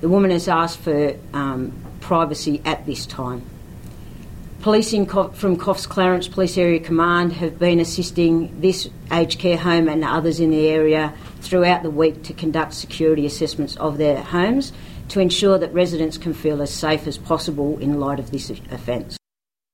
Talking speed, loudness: 165 wpm, -20 LUFS